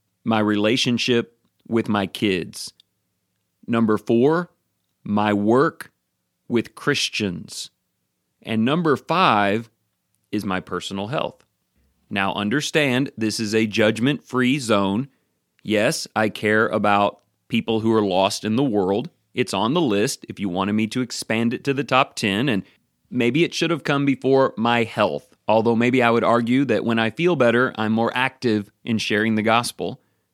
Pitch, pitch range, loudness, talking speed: 115 Hz, 105-125 Hz, -21 LUFS, 155 wpm